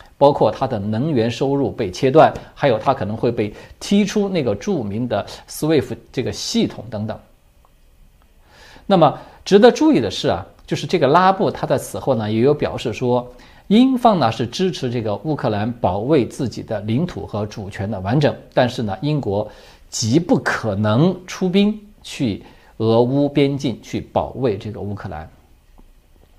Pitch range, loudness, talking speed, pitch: 105-155 Hz, -19 LUFS, 250 characters per minute, 120 Hz